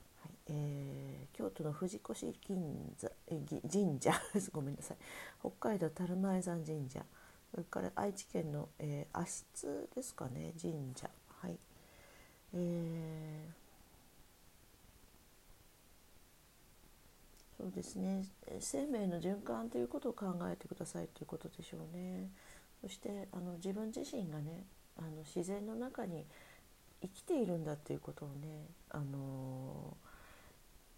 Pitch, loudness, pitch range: 160 Hz, -43 LUFS, 145-190 Hz